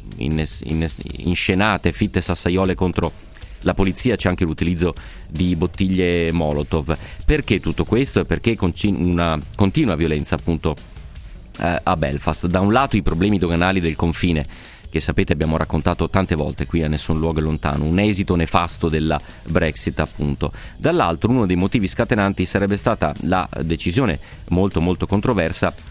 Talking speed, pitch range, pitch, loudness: 150 wpm, 80-95 Hz, 85 Hz, -19 LUFS